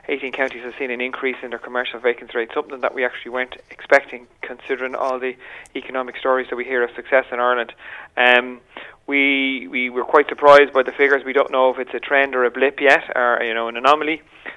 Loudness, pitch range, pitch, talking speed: -18 LUFS, 125-135 Hz, 130 Hz, 220 wpm